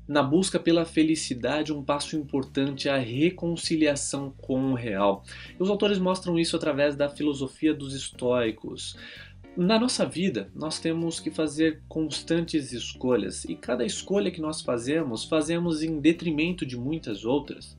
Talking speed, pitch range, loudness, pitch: 150 wpm, 135-165 Hz, -27 LUFS, 155 Hz